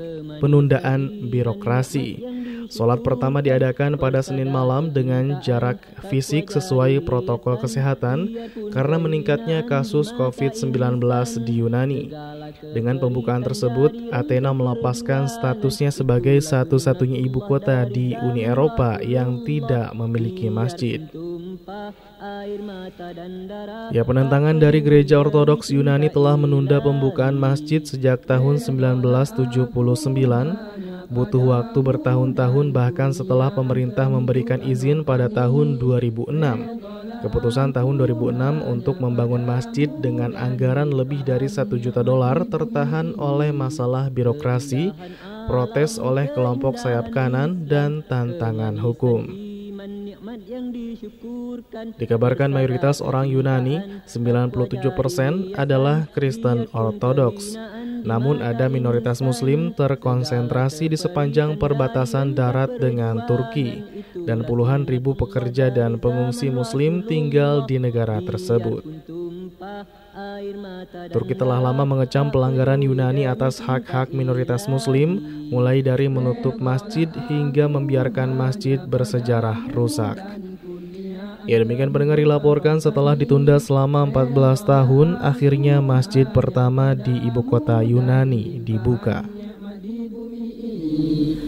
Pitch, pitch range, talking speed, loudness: 135 Hz, 125-150 Hz, 100 wpm, -20 LUFS